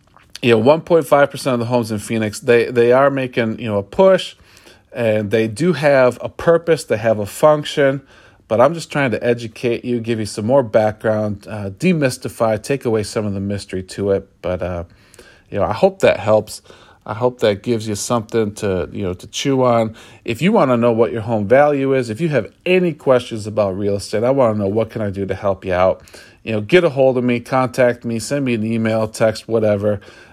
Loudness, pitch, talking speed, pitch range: -17 LUFS, 115 Hz, 230 wpm, 105-130 Hz